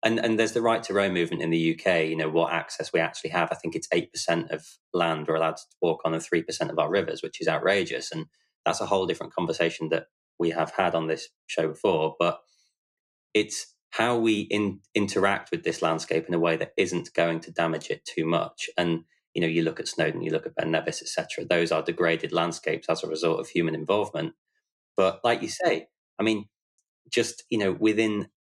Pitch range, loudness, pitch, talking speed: 80-105 Hz, -27 LUFS, 85 Hz, 225 wpm